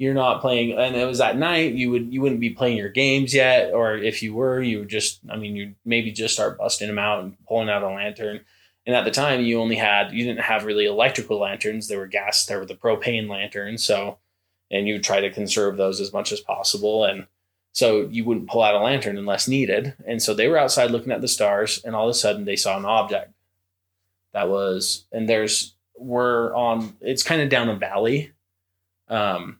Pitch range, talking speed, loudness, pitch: 100-120 Hz, 225 wpm, -22 LUFS, 110 Hz